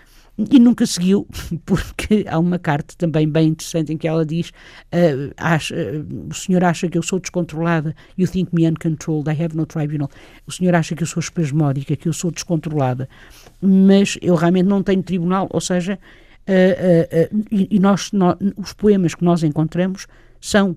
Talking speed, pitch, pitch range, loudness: 185 wpm, 170 Hz, 160-185 Hz, -18 LUFS